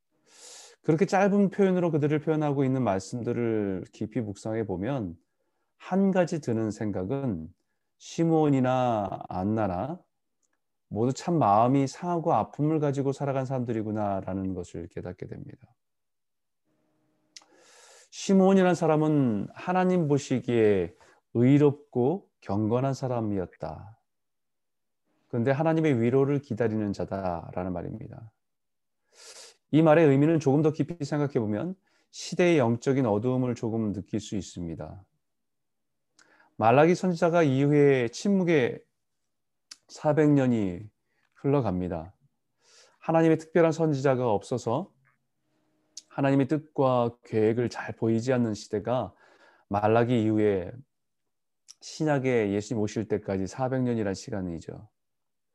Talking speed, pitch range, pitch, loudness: 255 characters per minute, 105-150 Hz, 125 Hz, -26 LUFS